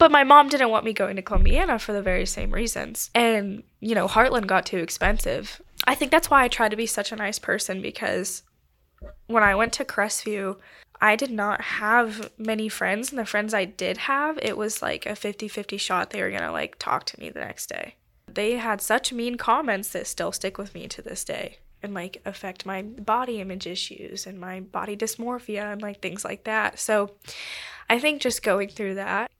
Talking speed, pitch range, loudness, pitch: 215 wpm, 195-230 Hz, -24 LUFS, 215 Hz